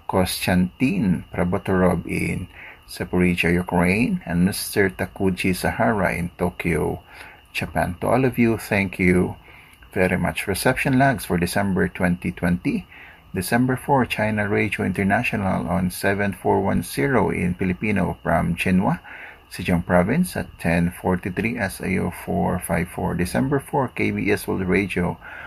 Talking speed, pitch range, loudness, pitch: 110 wpm, 90-105 Hz, -22 LUFS, 95 Hz